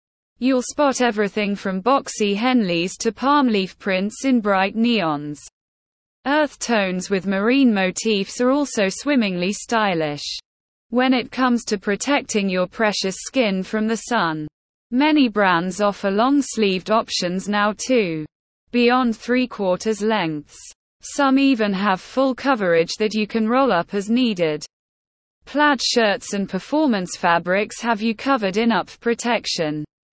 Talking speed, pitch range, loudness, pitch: 135 wpm, 190-250 Hz, -20 LUFS, 220 Hz